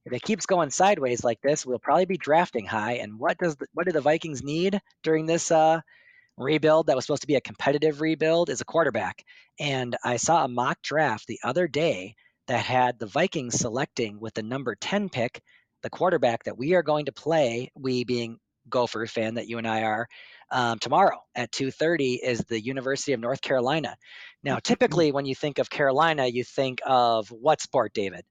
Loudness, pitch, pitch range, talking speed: -25 LUFS, 140 Hz, 120-165 Hz, 205 wpm